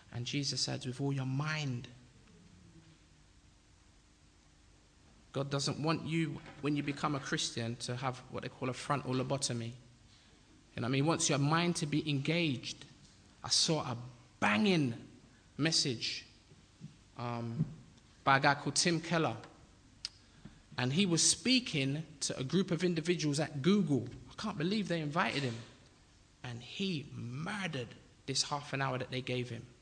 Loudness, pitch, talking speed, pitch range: -34 LUFS, 135 Hz, 150 wpm, 120-155 Hz